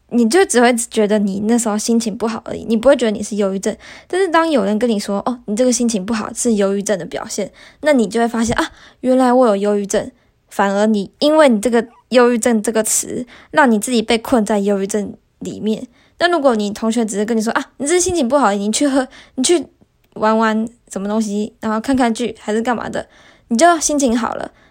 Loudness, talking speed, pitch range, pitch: -16 LUFS, 330 characters per minute, 210-255 Hz, 230 Hz